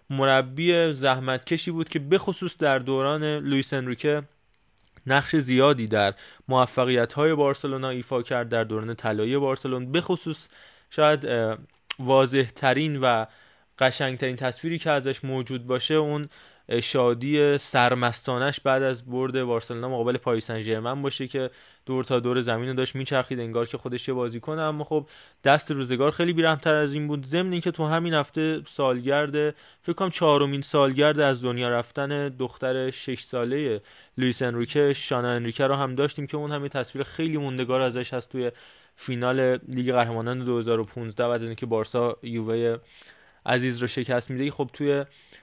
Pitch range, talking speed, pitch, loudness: 125-145 Hz, 150 wpm, 130 Hz, -25 LUFS